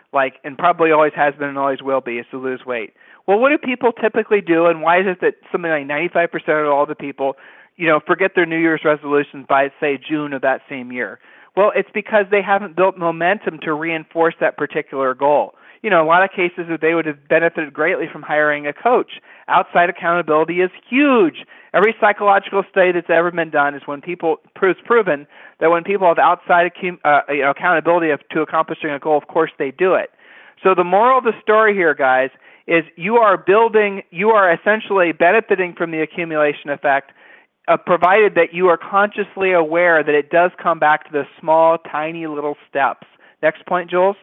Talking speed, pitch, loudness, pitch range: 205 wpm, 165 Hz, -17 LUFS, 150-190 Hz